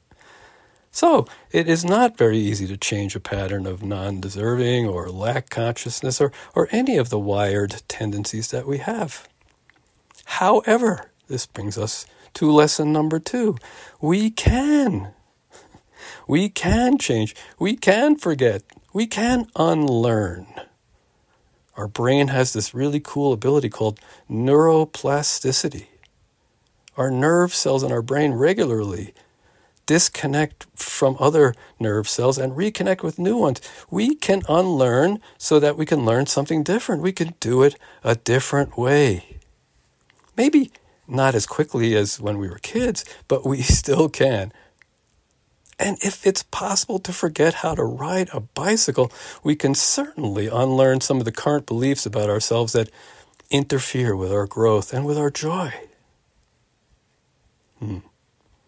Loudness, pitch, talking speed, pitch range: -20 LUFS, 135 Hz, 135 wpm, 110-175 Hz